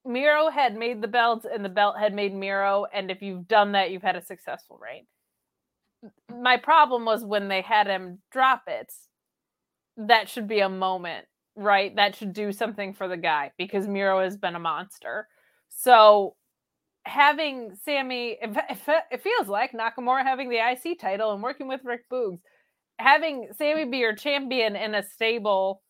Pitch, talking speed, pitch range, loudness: 220 Hz, 170 wpm, 195-255 Hz, -24 LUFS